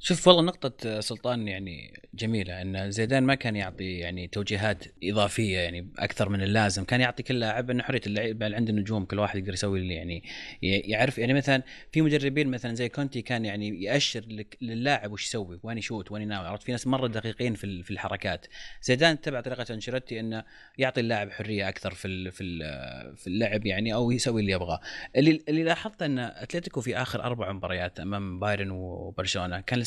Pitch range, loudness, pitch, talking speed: 100-125 Hz, -28 LUFS, 110 Hz, 185 wpm